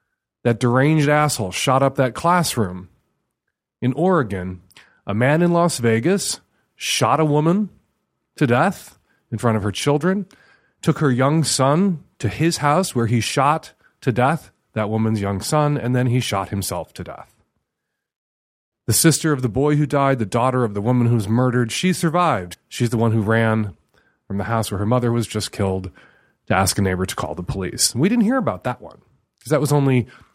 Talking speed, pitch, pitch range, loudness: 190 wpm, 125 Hz, 110-150 Hz, -19 LUFS